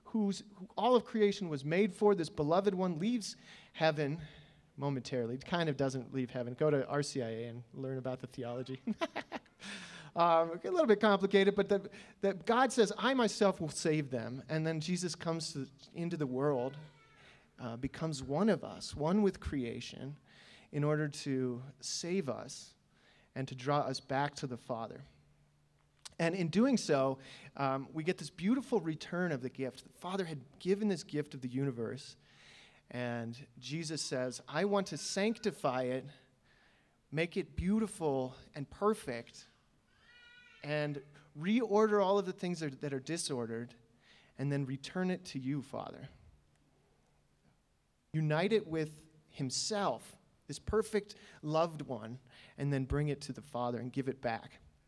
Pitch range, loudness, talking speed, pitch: 130-195 Hz, -35 LUFS, 160 wpm, 150 Hz